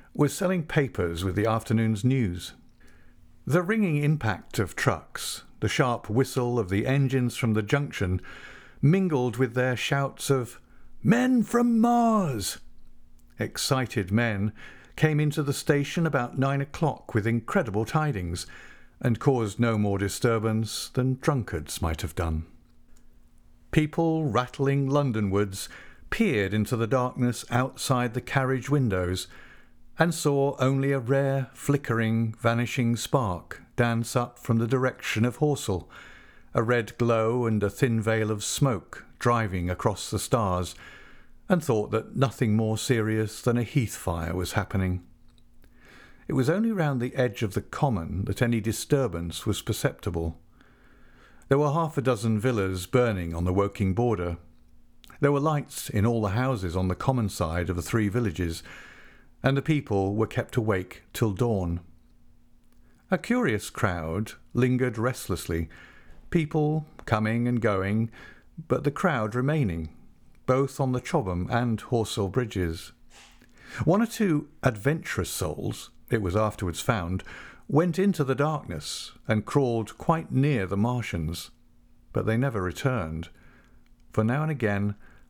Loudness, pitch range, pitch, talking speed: -27 LUFS, 100-135 Hz, 120 Hz, 140 wpm